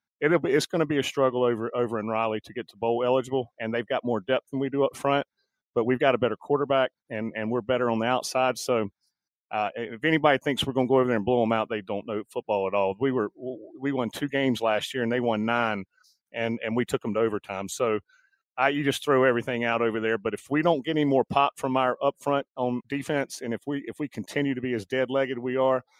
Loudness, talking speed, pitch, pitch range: -26 LUFS, 270 wpm, 125 Hz, 115-135 Hz